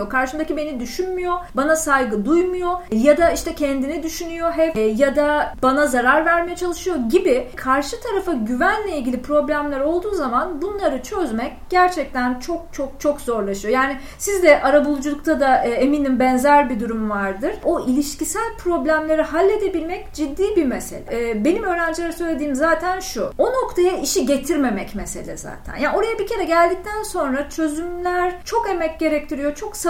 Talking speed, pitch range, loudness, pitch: 150 wpm, 275-360 Hz, -20 LUFS, 315 Hz